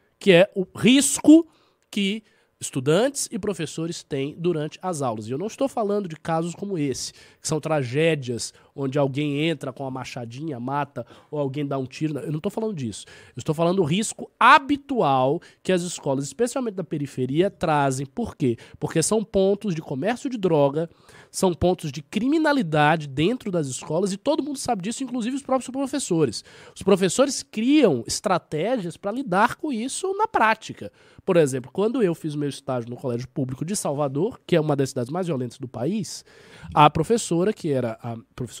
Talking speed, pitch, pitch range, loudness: 180 wpm, 165 Hz, 140-215 Hz, -23 LUFS